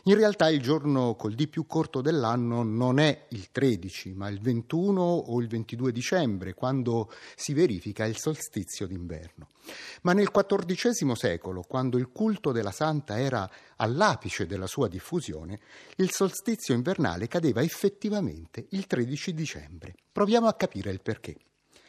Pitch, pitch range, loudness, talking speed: 130 Hz, 105-170 Hz, -28 LUFS, 145 wpm